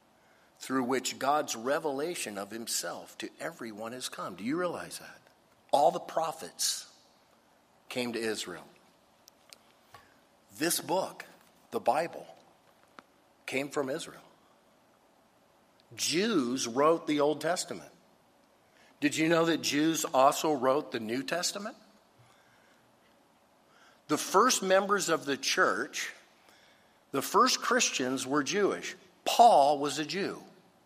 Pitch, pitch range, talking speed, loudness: 145 Hz, 125-165 Hz, 110 wpm, -30 LUFS